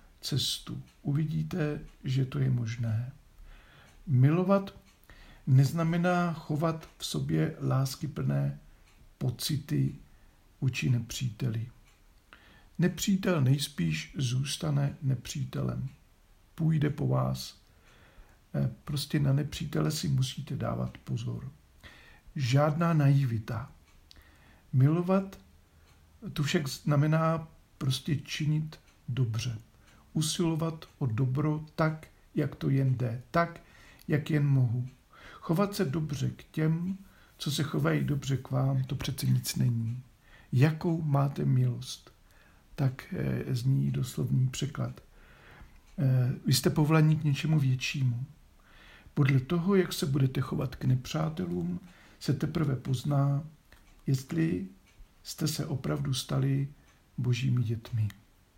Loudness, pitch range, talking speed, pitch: -30 LUFS, 125-155 Hz, 100 wpm, 140 Hz